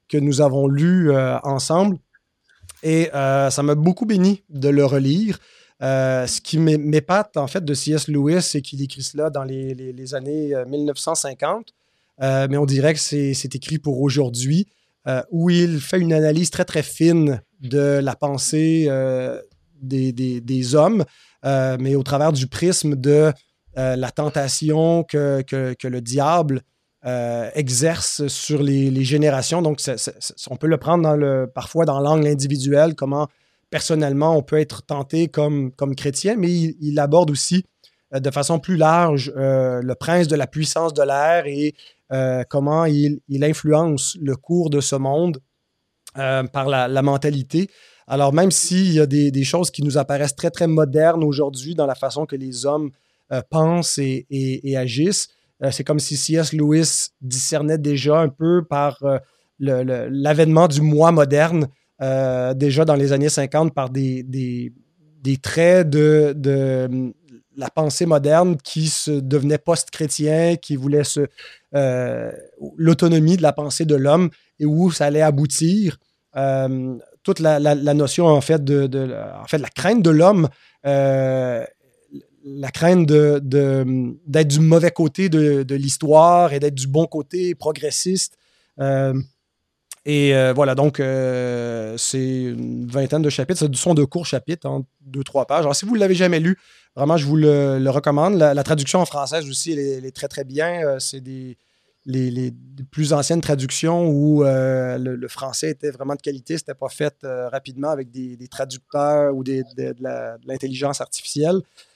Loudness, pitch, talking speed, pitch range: -19 LUFS, 145 Hz, 180 wpm, 135-160 Hz